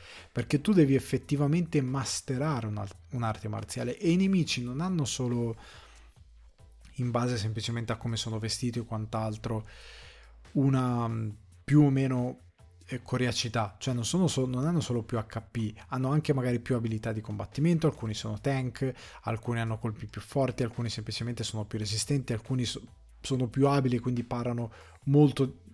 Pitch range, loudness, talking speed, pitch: 110-135 Hz, -30 LUFS, 150 wpm, 120 Hz